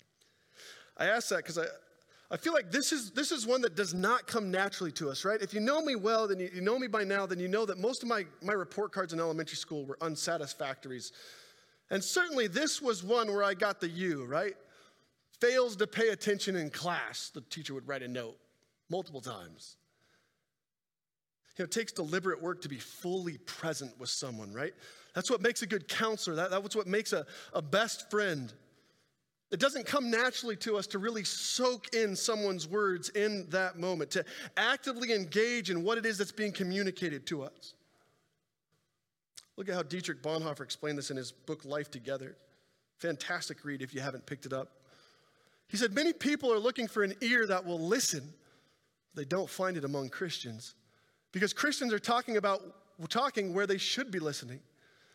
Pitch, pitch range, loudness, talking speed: 190 Hz, 155-225 Hz, -33 LUFS, 190 wpm